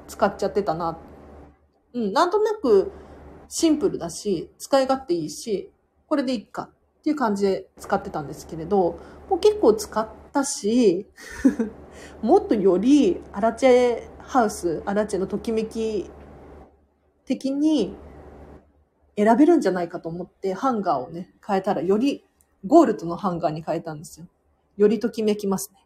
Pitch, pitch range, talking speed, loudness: 210 Hz, 170-270 Hz, 310 characters per minute, -23 LUFS